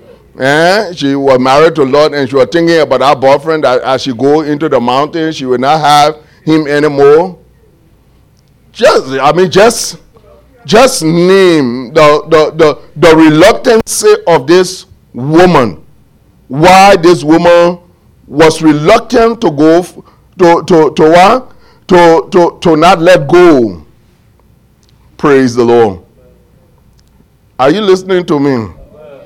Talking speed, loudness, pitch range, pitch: 135 wpm, -7 LUFS, 140-180 Hz, 160 Hz